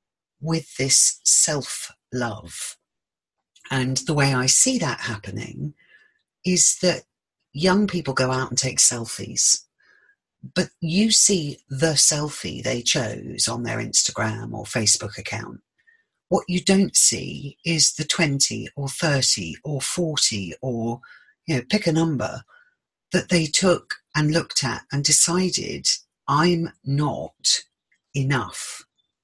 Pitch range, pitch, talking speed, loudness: 130-180 Hz, 150 Hz, 125 wpm, -21 LUFS